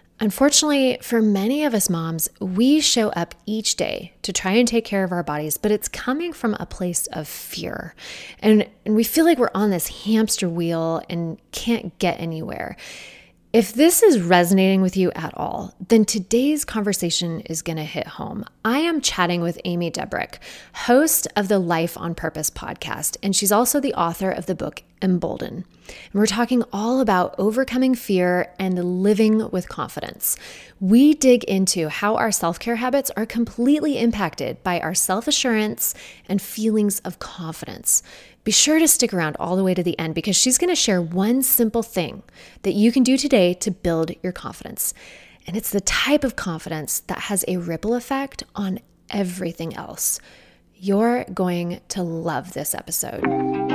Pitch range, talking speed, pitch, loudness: 175-235 Hz, 175 wpm, 200 Hz, -20 LUFS